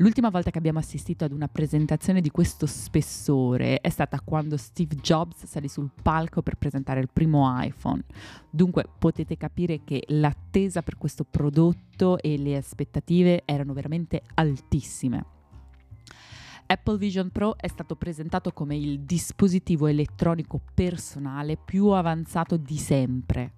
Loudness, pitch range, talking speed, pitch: -26 LUFS, 145-170 Hz, 135 wpm, 155 Hz